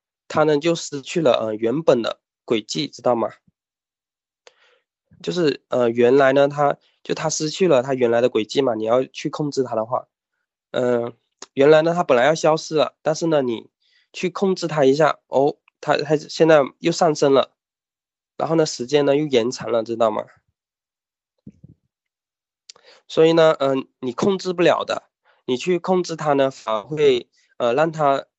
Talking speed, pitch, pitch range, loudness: 230 characters per minute, 150 Hz, 130-165 Hz, -20 LUFS